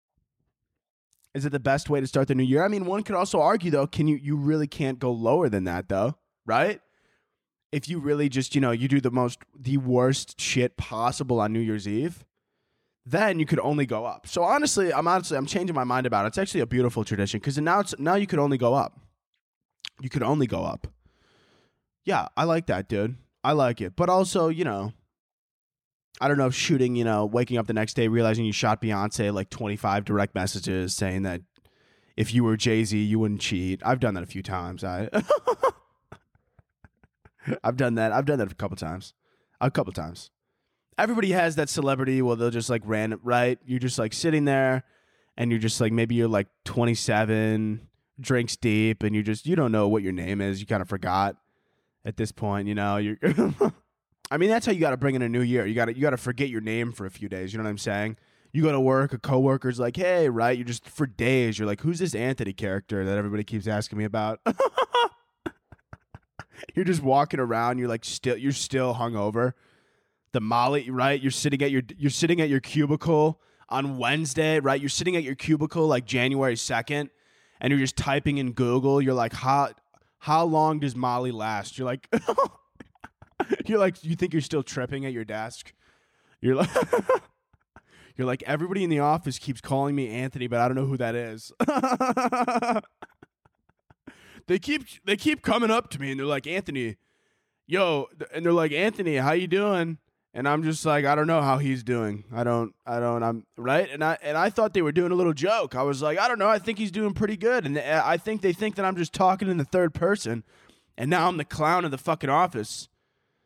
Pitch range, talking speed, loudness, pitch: 115-160 Hz, 210 wpm, -25 LUFS, 130 Hz